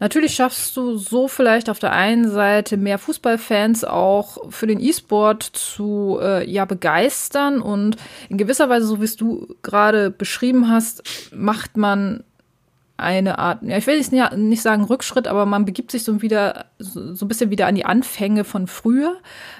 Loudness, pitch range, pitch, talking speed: -18 LUFS, 205-245 Hz, 215 Hz, 175 wpm